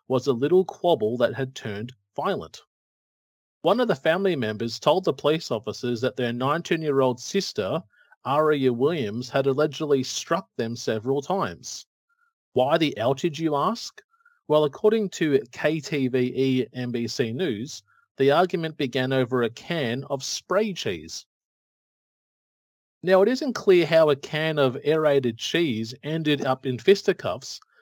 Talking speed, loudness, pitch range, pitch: 140 wpm, -24 LUFS, 130-180 Hz, 145 Hz